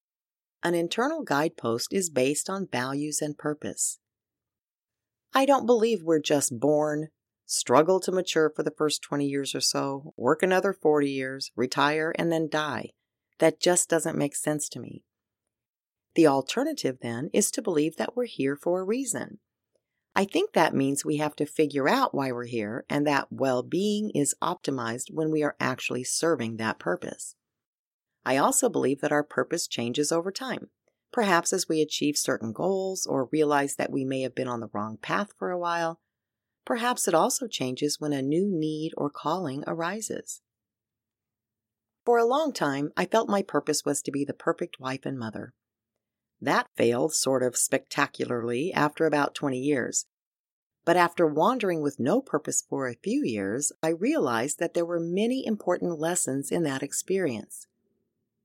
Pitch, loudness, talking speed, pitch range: 150 Hz, -27 LUFS, 165 wpm, 130-170 Hz